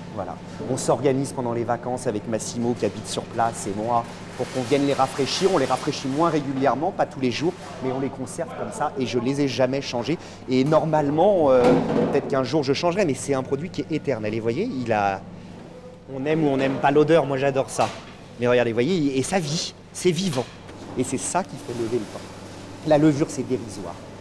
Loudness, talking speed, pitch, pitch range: -23 LUFS, 230 wpm, 130 Hz, 120-145 Hz